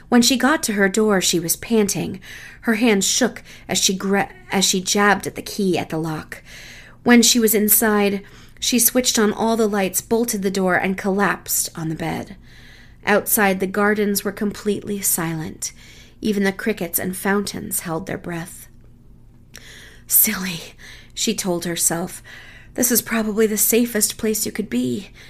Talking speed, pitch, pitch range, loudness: 165 wpm, 200 Hz, 175-220 Hz, -19 LUFS